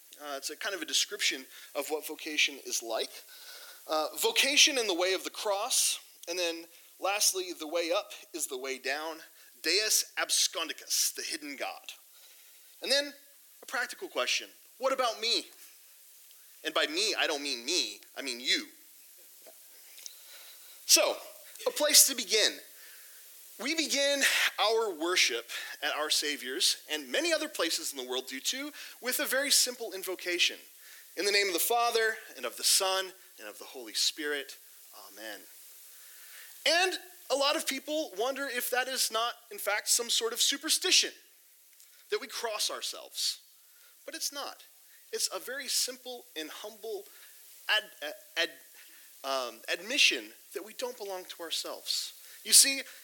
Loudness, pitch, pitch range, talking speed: -29 LUFS, 280 Hz, 220-350 Hz, 155 wpm